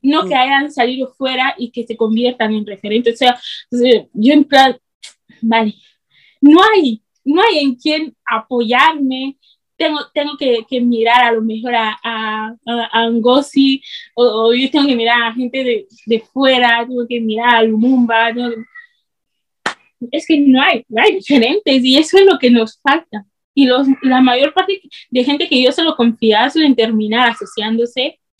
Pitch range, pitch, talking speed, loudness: 230-275 Hz, 250 Hz, 175 wpm, -13 LUFS